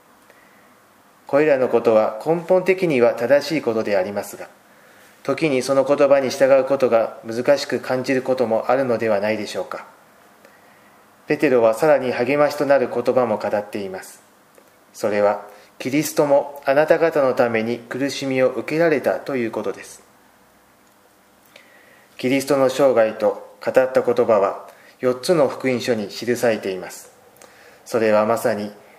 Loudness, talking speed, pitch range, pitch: -19 LUFS, 295 characters per minute, 115-155 Hz, 130 Hz